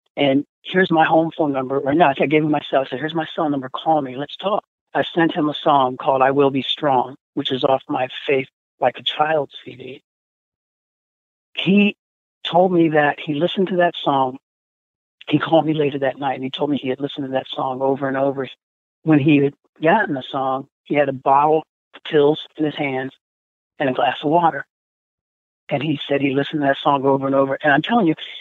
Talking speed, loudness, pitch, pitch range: 220 wpm, -19 LUFS, 140 Hz, 130-155 Hz